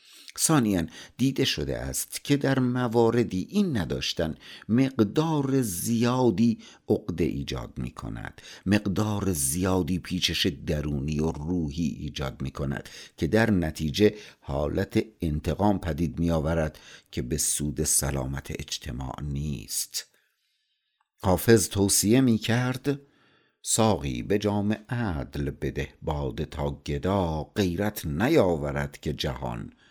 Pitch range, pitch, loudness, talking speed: 75-110 Hz, 90 Hz, -27 LUFS, 110 wpm